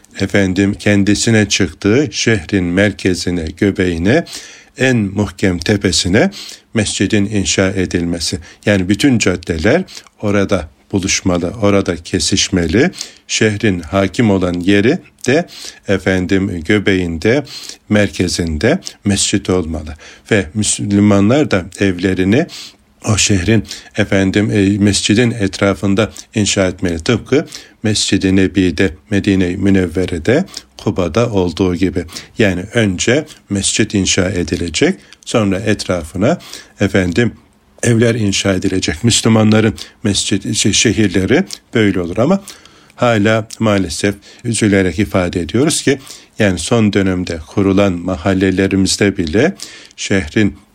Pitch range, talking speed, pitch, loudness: 95-105 Hz, 90 wpm, 100 Hz, -14 LUFS